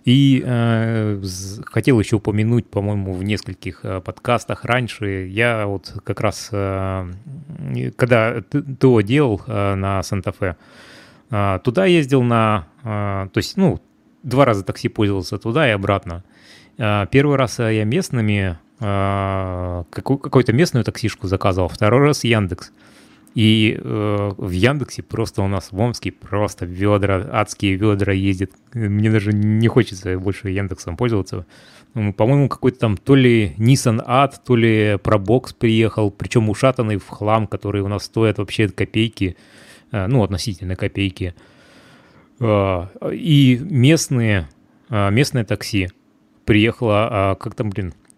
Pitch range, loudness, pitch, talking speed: 100-120 Hz, -19 LUFS, 105 Hz, 135 wpm